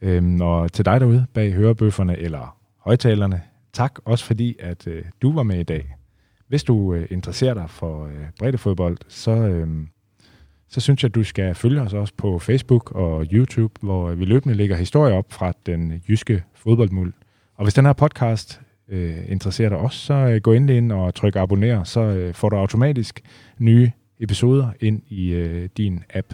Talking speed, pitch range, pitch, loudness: 185 wpm, 90-120 Hz, 105 Hz, -20 LUFS